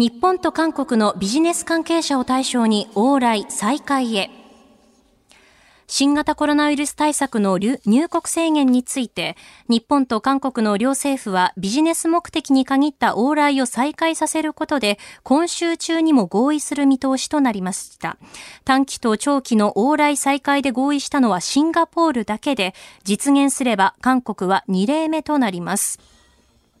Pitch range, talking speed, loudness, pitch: 225-300 Hz, 295 characters per minute, -19 LUFS, 270 Hz